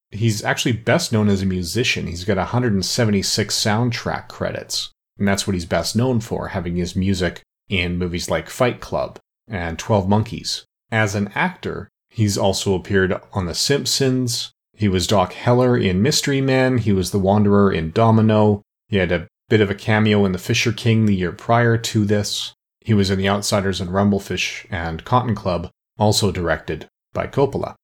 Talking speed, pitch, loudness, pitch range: 175 wpm, 105 Hz, -19 LUFS, 95-115 Hz